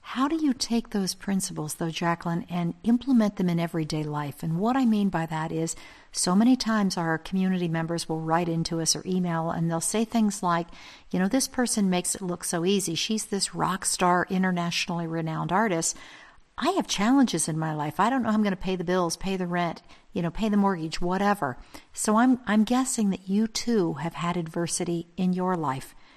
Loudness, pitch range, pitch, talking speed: -26 LUFS, 165-210 Hz, 180 Hz, 210 wpm